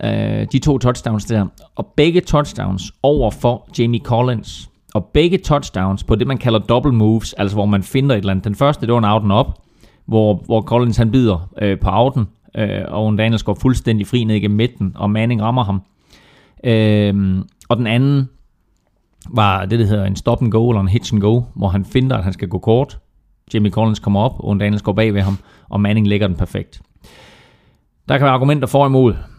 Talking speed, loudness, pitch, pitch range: 210 wpm, -16 LUFS, 110 Hz, 100-120 Hz